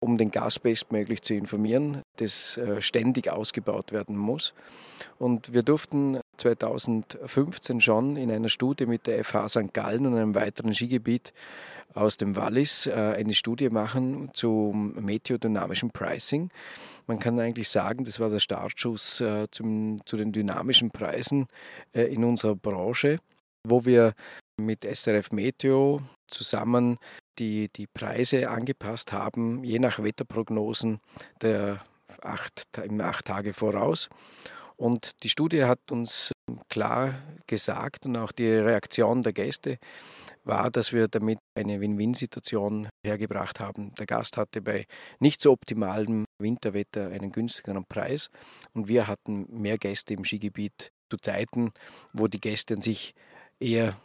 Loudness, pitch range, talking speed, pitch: -27 LUFS, 105-120 Hz, 130 wpm, 110 Hz